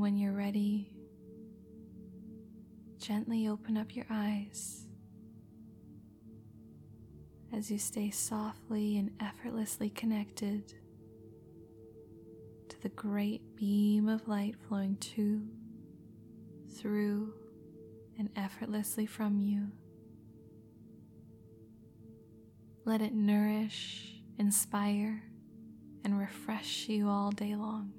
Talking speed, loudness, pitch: 80 wpm, -35 LUFS, 205 Hz